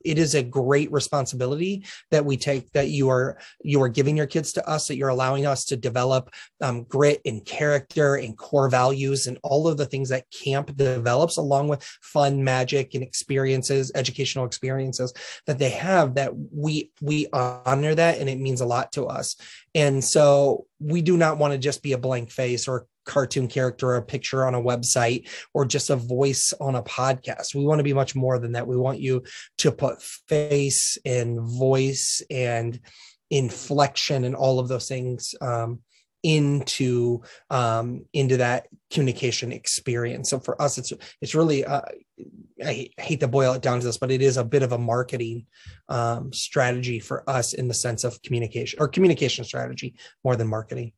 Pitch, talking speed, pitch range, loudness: 135 Hz, 185 wpm, 125-140 Hz, -24 LUFS